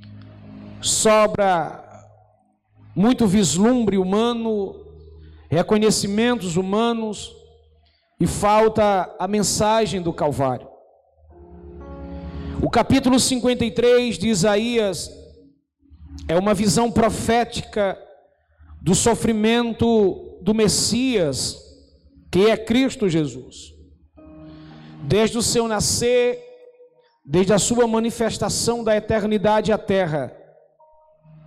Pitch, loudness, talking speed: 205 Hz, -19 LUFS, 80 wpm